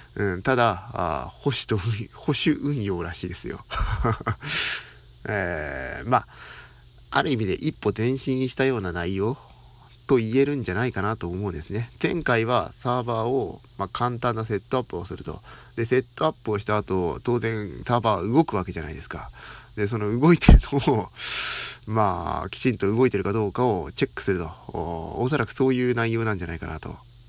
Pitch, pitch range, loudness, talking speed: 115 Hz, 100-125 Hz, -25 LUFS, 350 characters per minute